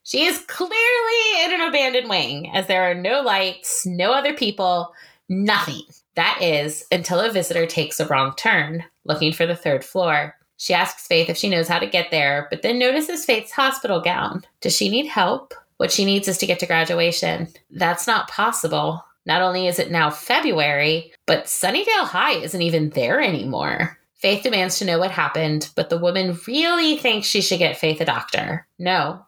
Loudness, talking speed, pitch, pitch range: -20 LUFS, 190 wpm, 180 Hz, 165-225 Hz